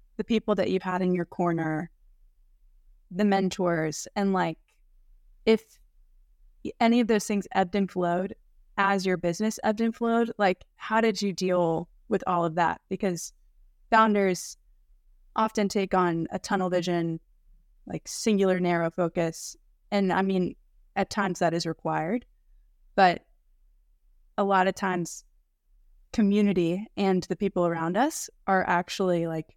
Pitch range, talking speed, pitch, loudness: 170-205 Hz, 140 wpm, 185 Hz, -27 LUFS